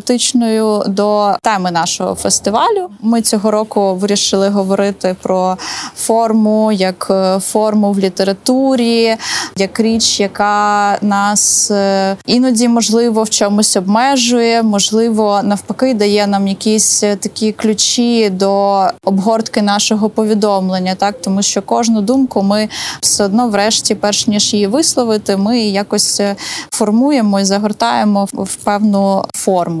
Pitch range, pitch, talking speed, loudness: 200-225 Hz, 210 Hz, 115 wpm, -12 LUFS